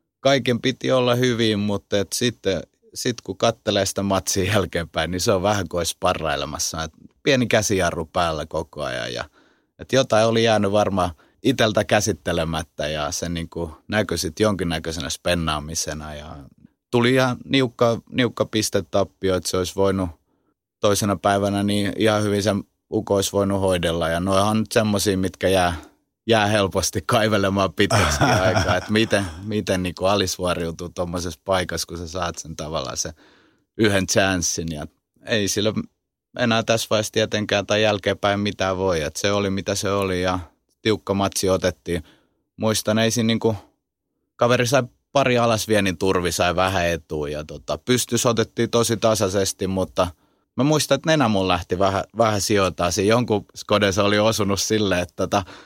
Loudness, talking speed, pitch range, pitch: -21 LUFS, 150 wpm, 90-110 Hz, 100 Hz